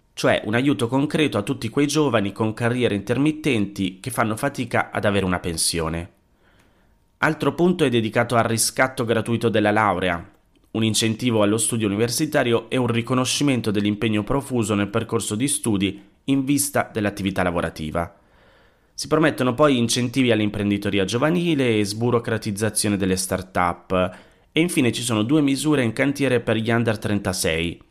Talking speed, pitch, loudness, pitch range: 145 wpm, 115 Hz, -21 LUFS, 100-130 Hz